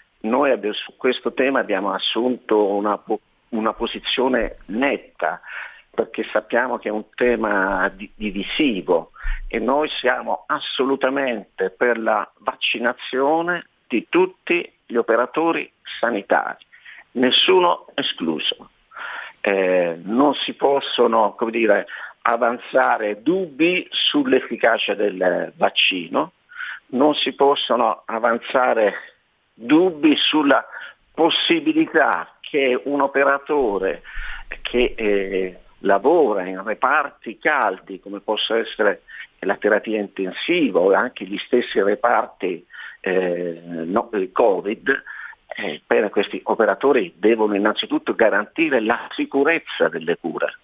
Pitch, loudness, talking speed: 125 Hz, -20 LUFS, 100 wpm